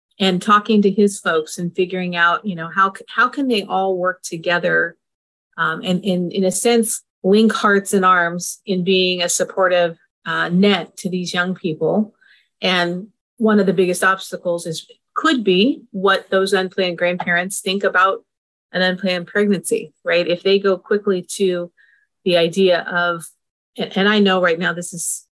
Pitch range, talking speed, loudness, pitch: 175-200 Hz, 170 wpm, -18 LUFS, 190 Hz